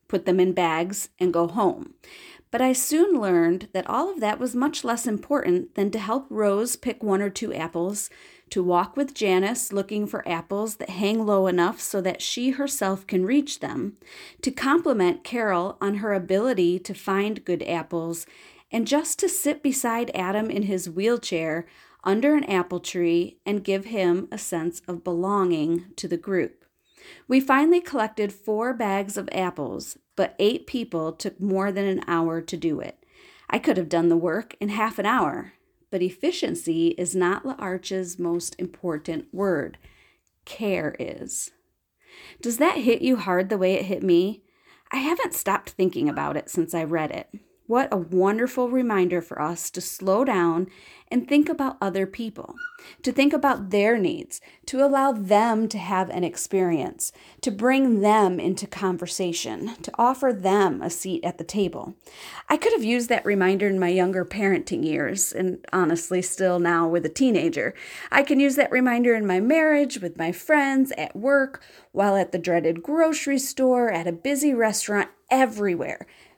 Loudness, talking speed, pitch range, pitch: -24 LUFS, 170 wpm, 180-265 Hz, 200 Hz